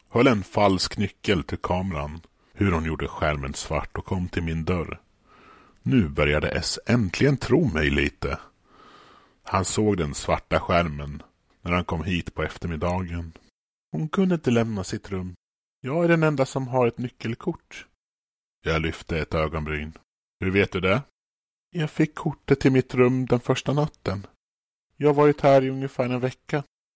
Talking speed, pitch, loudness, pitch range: 160 wpm, 95 Hz, -24 LUFS, 80-130 Hz